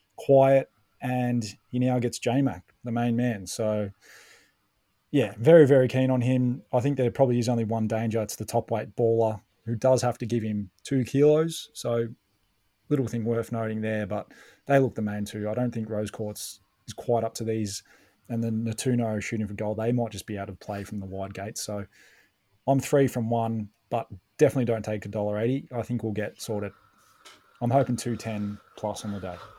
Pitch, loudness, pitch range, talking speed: 115 Hz, -27 LUFS, 105-125 Hz, 205 wpm